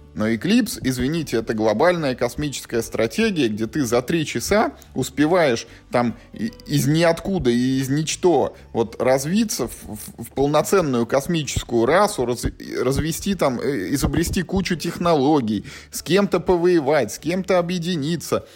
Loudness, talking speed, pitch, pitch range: -21 LUFS, 125 wpm, 145 Hz, 120-175 Hz